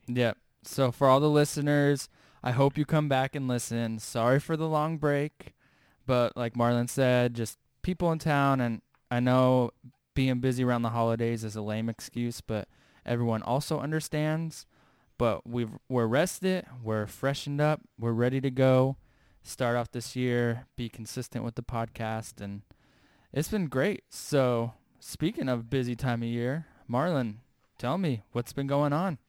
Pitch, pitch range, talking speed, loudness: 125 Hz, 115-140 Hz, 165 wpm, -29 LUFS